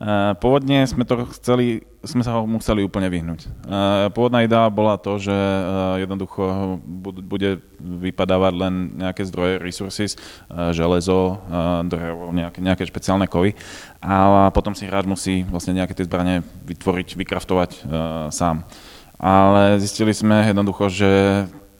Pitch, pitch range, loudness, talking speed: 95 Hz, 90-100 Hz, -20 LUFS, 125 wpm